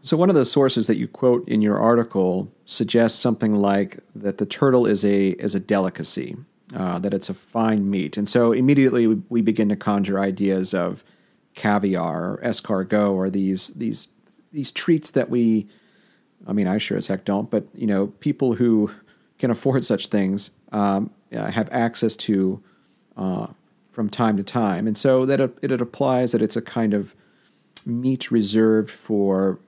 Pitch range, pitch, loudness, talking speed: 100-120 Hz, 110 Hz, -21 LUFS, 180 wpm